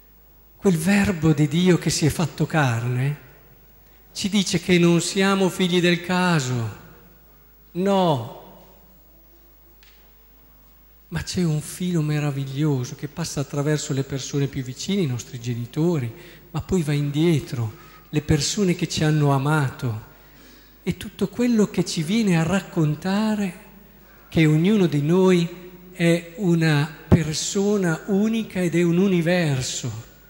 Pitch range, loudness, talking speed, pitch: 150-185 Hz, -22 LUFS, 125 wpm, 170 Hz